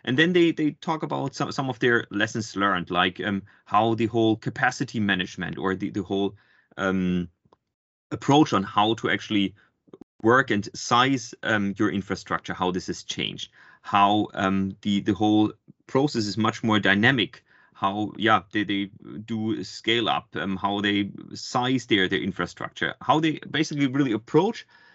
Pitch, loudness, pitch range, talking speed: 105 Hz, -24 LUFS, 95-125 Hz, 165 wpm